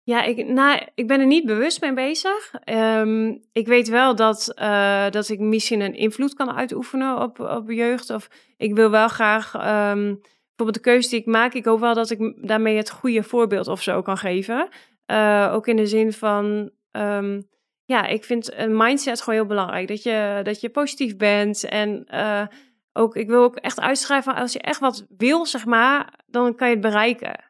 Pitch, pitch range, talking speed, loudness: 225 Hz, 215-250 Hz, 200 wpm, -20 LUFS